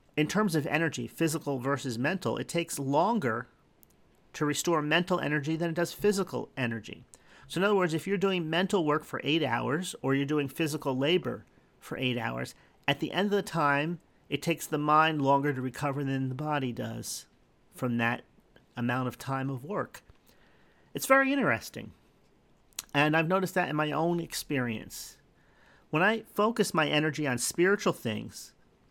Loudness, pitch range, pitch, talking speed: -29 LUFS, 135-170 Hz, 150 Hz, 170 wpm